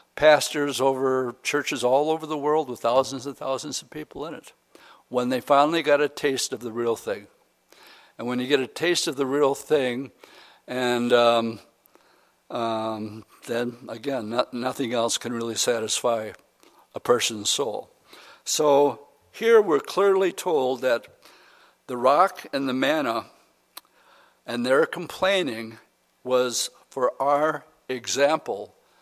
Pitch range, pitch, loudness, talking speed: 120-145 Hz, 135 Hz, -24 LUFS, 140 wpm